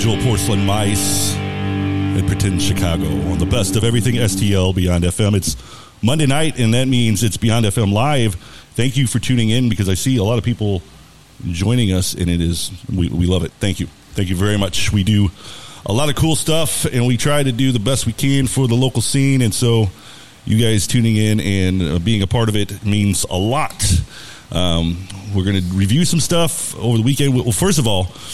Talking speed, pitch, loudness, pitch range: 210 wpm, 105 Hz, -17 LUFS, 95-120 Hz